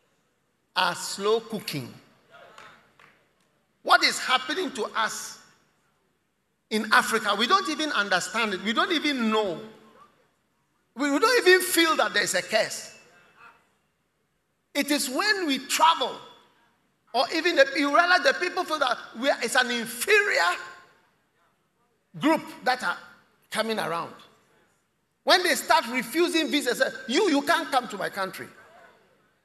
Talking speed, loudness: 130 wpm, -24 LUFS